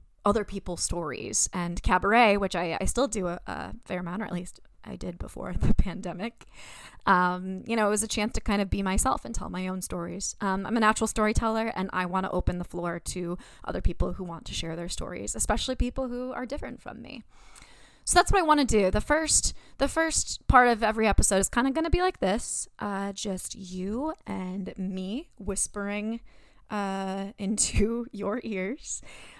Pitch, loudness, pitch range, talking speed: 205 Hz, -28 LUFS, 185-235 Hz, 205 wpm